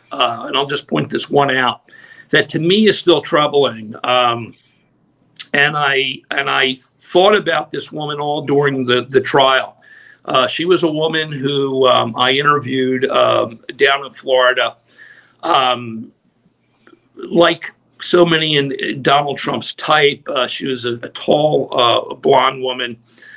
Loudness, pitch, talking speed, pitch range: -15 LUFS, 135 Hz, 150 wpm, 125-155 Hz